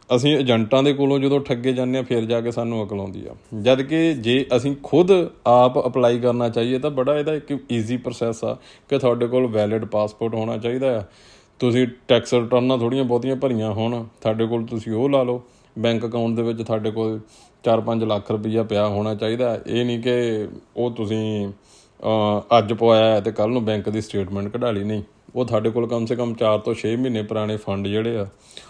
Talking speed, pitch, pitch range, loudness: 190 wpm, 115 Hz, 110-125 Hz, -21 LUFS